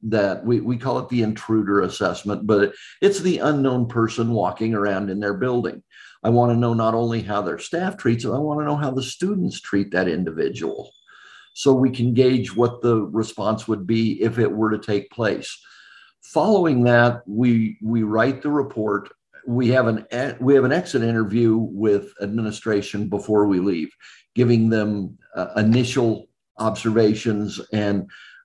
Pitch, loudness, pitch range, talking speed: 115 Hz, -21 LUFS, 105-125 Hz, 170 wpm